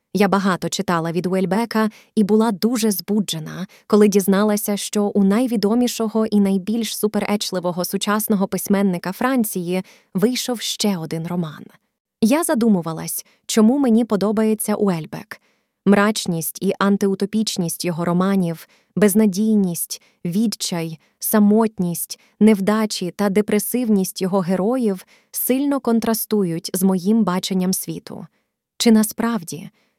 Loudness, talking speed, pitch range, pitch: -19 LUFS, 100 wpm, 185-220 Hz, 205 Hz